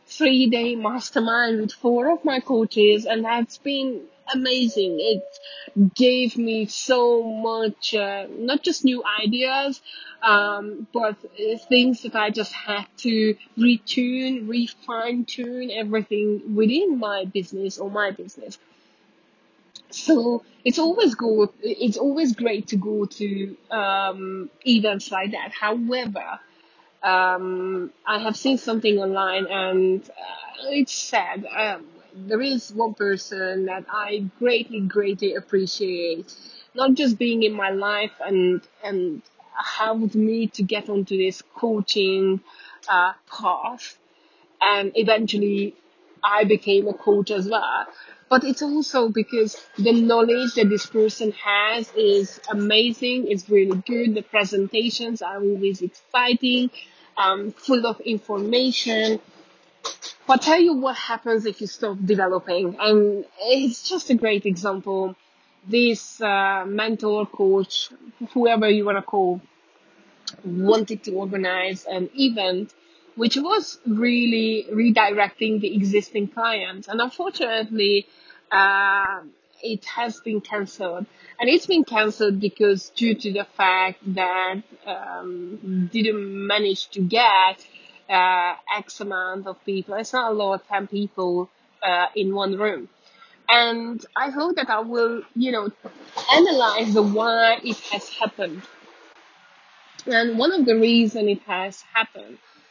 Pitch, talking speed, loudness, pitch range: 215 Hz, 130 wpm, -22 LUFS, 200-240 Hz